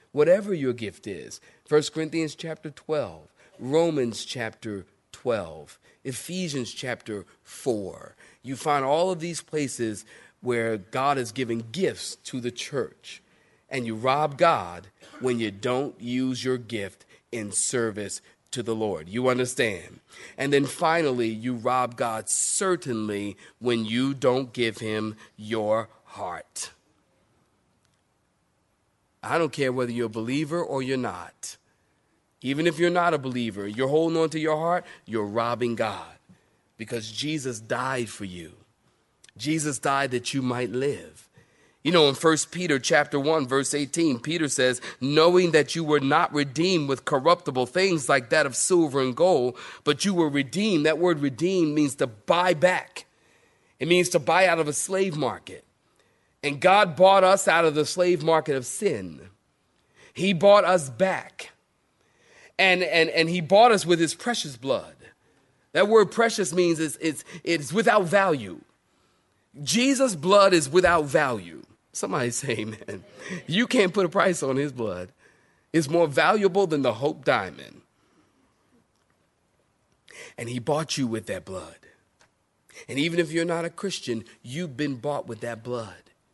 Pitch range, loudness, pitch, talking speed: 120-170 Hz, -24 LUFS, 140 Hz, 150 wpm